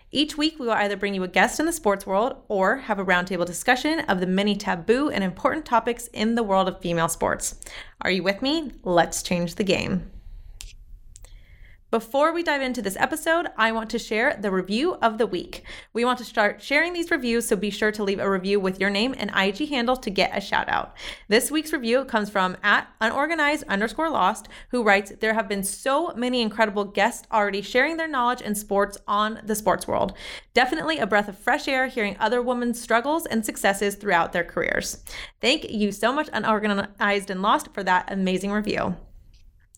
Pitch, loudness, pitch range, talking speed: 215 Hz, -23 LUFS, 195-250 Hz, 200 wpm